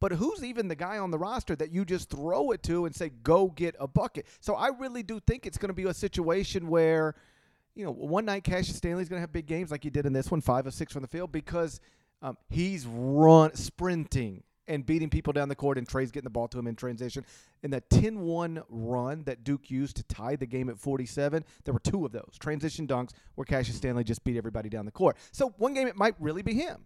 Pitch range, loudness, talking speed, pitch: 130-175 Hz, -30 LUFS, 250 wpm, 155 Hz